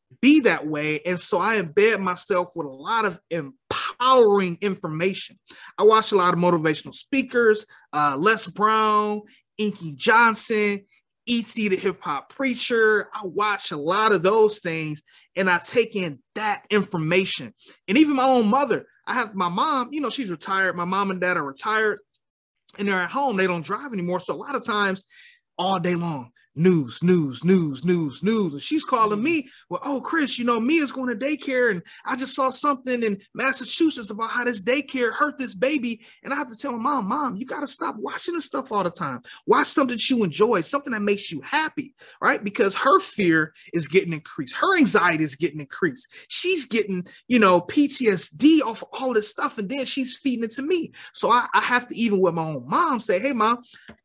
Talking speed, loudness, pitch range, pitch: 200 wpm, -22 LUFS, 180-260 Hz, 215 Hz